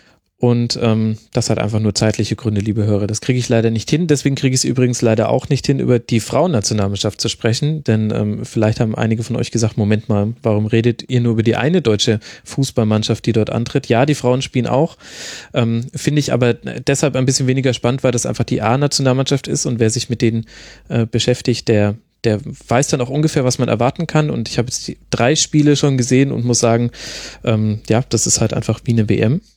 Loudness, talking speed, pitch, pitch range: -16 LUFS, 220 wpm, 120 Hz, 110-130 Hz